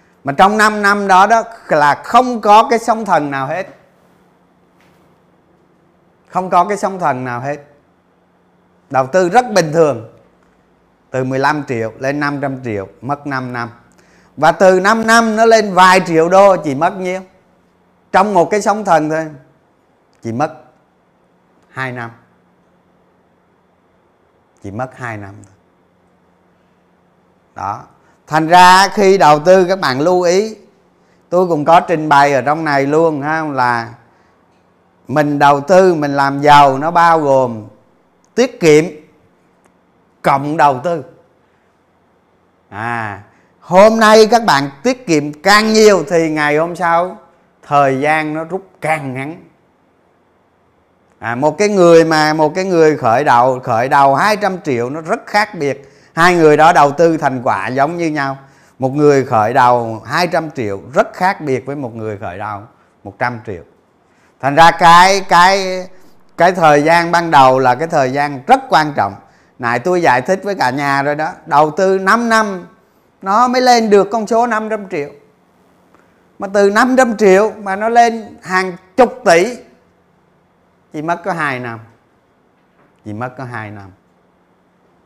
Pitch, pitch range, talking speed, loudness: 155 Hz, 130-185 Hz, 155 wpm, -12 LUFS